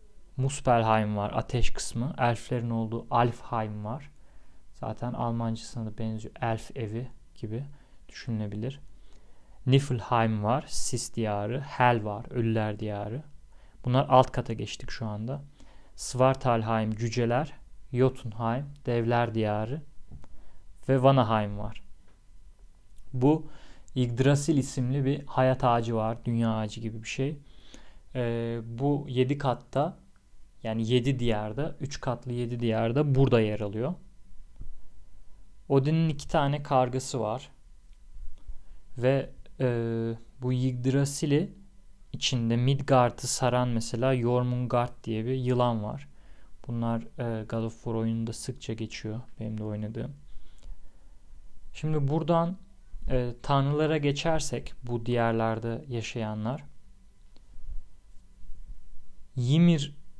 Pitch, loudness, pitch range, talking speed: 115 Hz, -29 LUFS, 105-130 Hz, 100 wpm